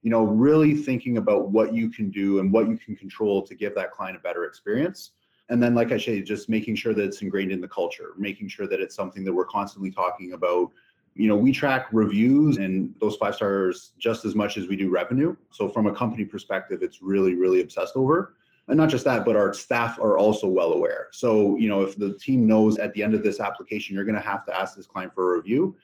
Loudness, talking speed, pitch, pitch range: -24 LUFS, 245 wpm, 110 Hz, 100-120 Hz